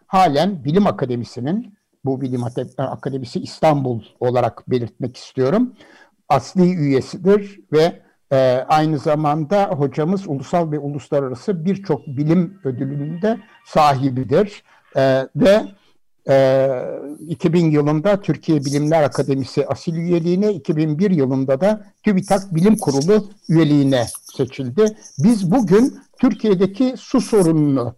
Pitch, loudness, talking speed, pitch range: 155 Hz, -18 LUFS, 100 wpm, 135-195 Hz